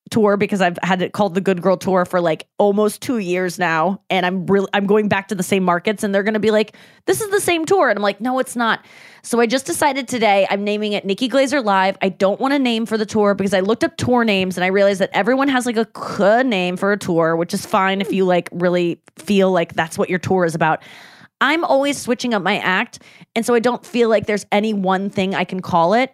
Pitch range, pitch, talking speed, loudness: 185-225 Hz, 200 Hz, 265 wpm, -18 LUFS